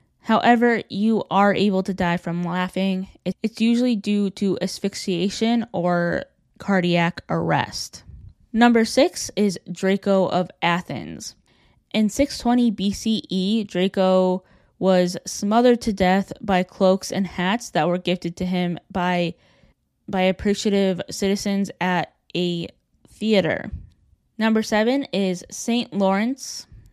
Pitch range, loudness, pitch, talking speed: 180-220 Hz, -21 LUFS, 195 Hz, 115 wpm